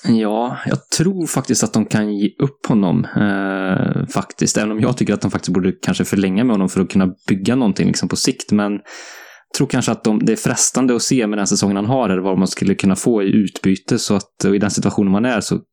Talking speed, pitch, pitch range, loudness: 245 wpm, 105 Hz, 95-115 Hz, -17 LUFS